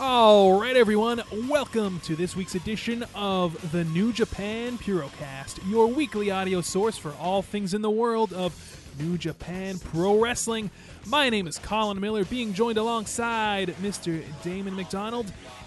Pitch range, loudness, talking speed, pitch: 180-225 Hz, -26 LUFS, 150 wpm, 205 Hz